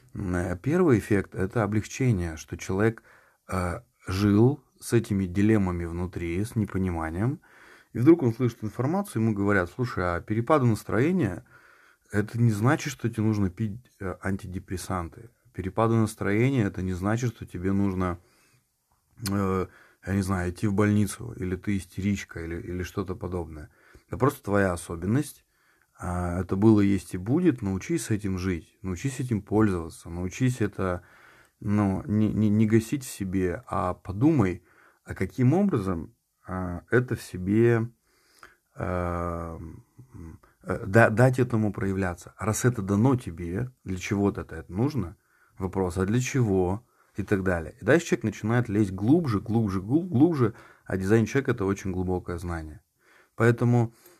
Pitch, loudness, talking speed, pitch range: 100 Hz, -26 LUFS, 140 wpm, 95-115 Hz